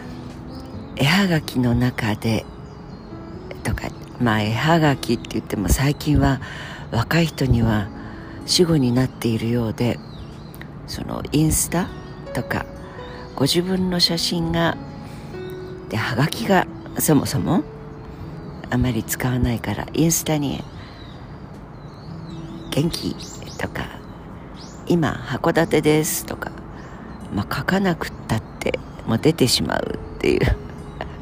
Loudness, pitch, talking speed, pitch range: -21 LUFS, 140 Hz, 190 characters per minute, 115-160 Hz